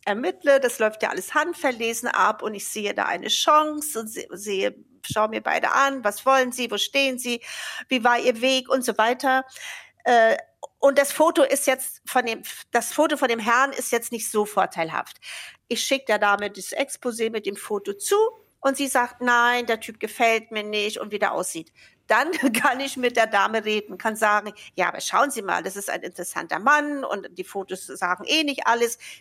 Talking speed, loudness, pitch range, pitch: 200 wpm, -23 LUFS, 215-275 Hz, 240 Hz